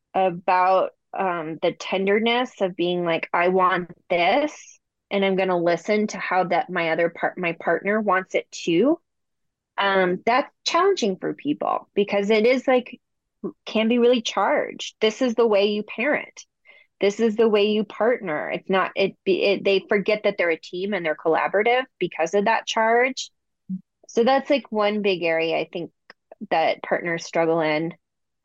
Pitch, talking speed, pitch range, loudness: 200 Hz, 170 wpm, 175-235 Hz, -22 LUFS